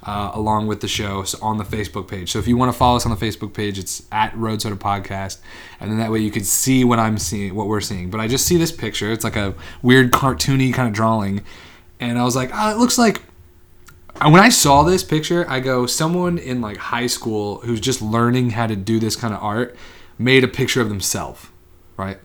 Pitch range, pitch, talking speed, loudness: 100-125 Hz, 110 Hz, 245 wpm, -18 LUFS